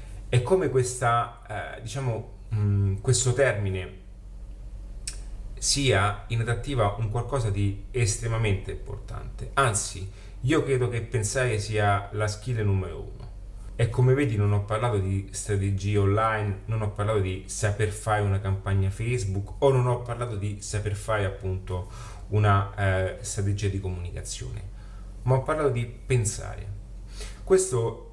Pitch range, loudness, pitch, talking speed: 100-120 Hz, -26 LUFS, 105 Hz, 135 wpm